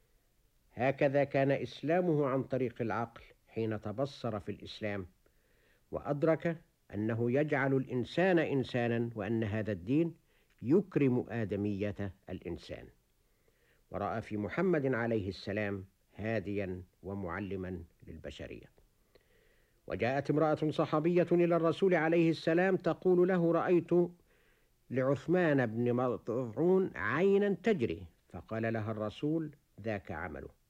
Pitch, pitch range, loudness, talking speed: 125 Hz, 105-160 Hz, -33 LUFS, 95 wpm